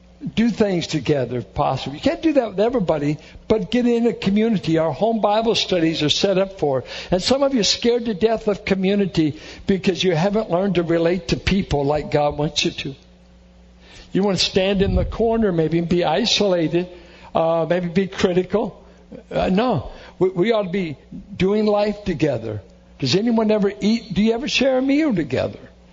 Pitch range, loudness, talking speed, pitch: 160-215 Hz, -20 LUFS, 190 wpm, 190 Hz